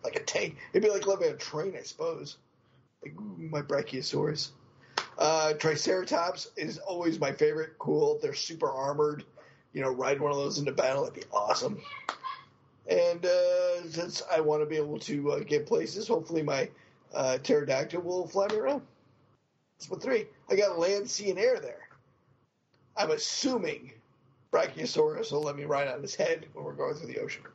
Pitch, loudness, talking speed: 180 Hz, -30 LUFS, 175 wpm